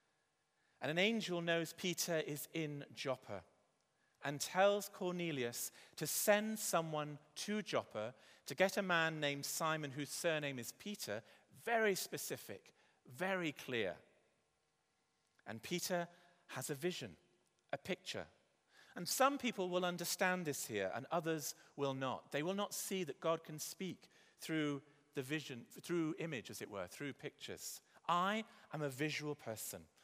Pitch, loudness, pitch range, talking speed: 160 Hz, -41 LUFS, 135-180 Hz, 140 wpm